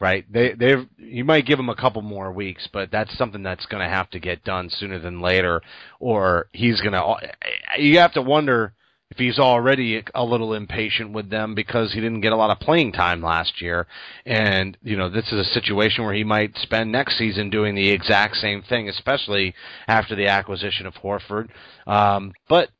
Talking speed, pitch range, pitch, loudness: 205 wpm, 95-120 Hz, 105 Hz, -21 LUFS